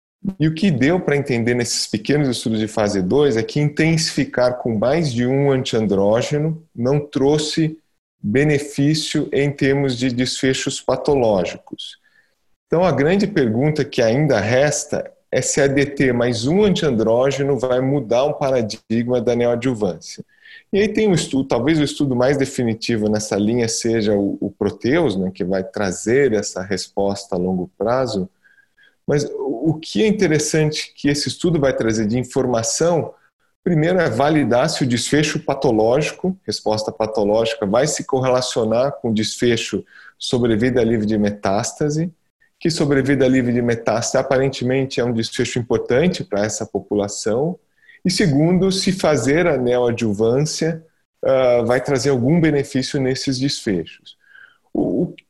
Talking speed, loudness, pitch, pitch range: 140 wpm, -19 LUFS, 135 Hz, 115-150 Hz